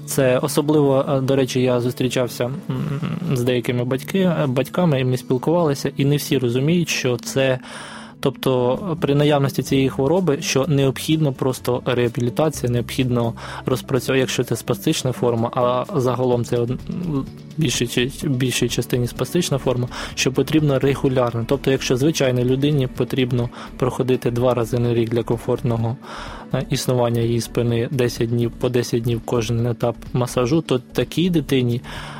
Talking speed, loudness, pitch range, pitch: 135 wpm, -20 LUFS, 120-140 Hz, 130 Hz